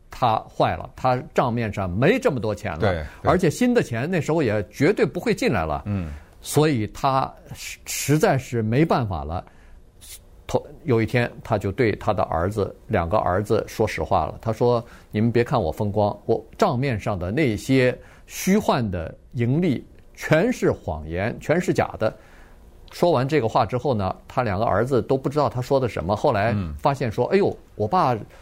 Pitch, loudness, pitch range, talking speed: 120 Hz, -23 LUFS, 105-140 Hz, 255 characters per minute